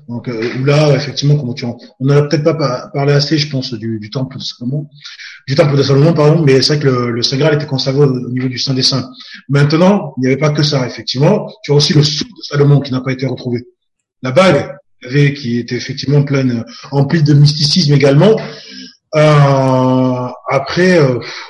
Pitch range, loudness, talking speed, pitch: 125-150 Hz, -13 LUFS, 210 wpm, 140 Hz